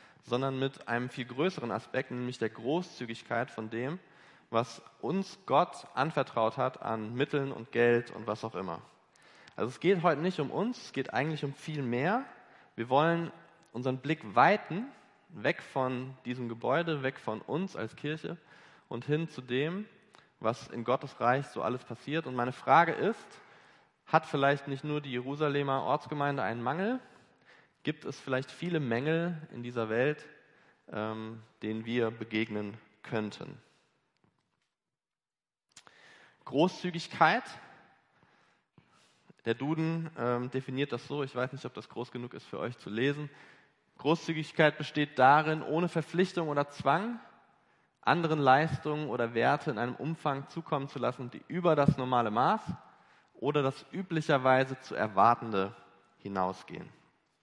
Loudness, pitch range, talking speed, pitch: -32 LUFS, 120-155 Hz, 140 wpm, 135 Hz